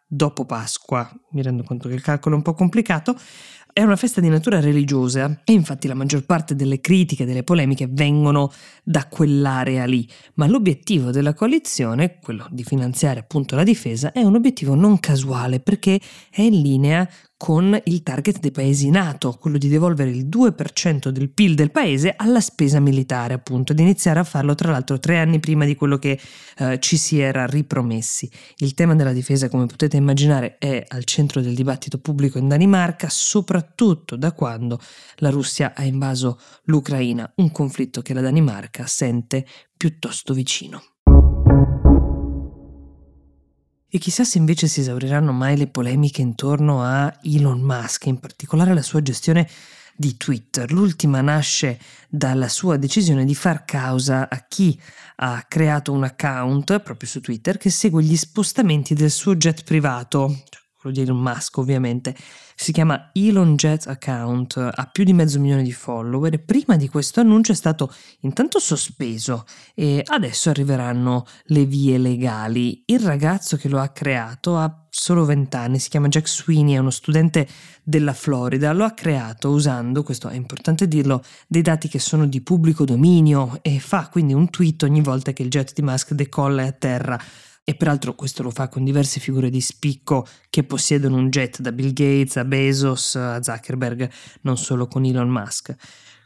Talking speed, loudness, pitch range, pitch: 165 wpm, -19 LUFS, 130-160 Hz, 140 Hz